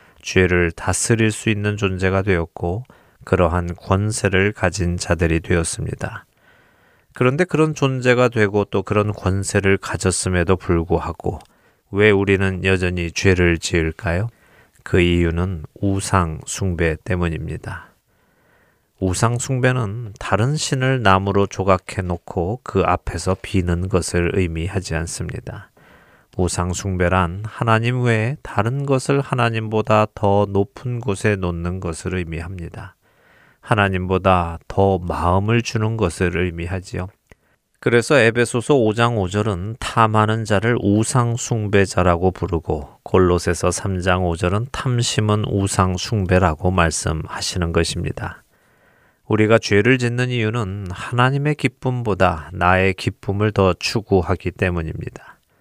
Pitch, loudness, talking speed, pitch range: 95 Hz, -19 LUFS, 270 characters per minute, 90-110 Hz